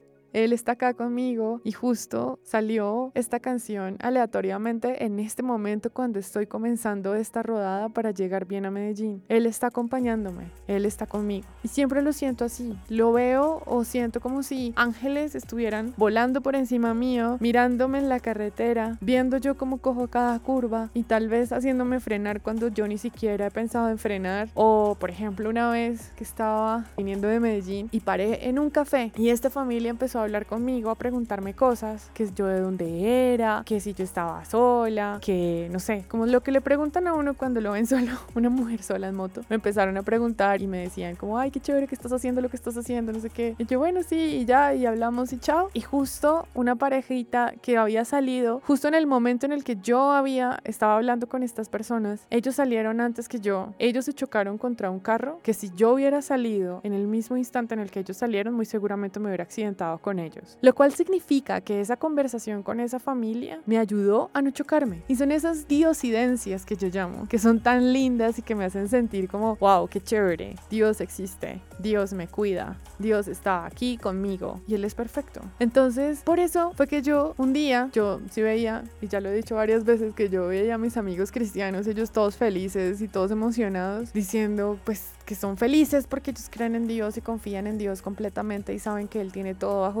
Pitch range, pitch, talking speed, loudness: 205-250 Hz, 230 Hz, 205 wpm, -26 LUFS